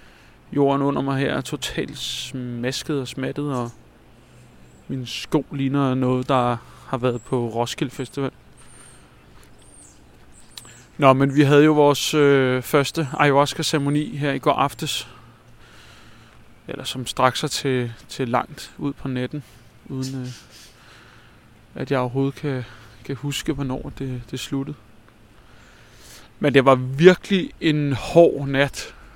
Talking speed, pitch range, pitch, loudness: 130 wpm, 125-145 Hz, 135 Hz, -21 LUFS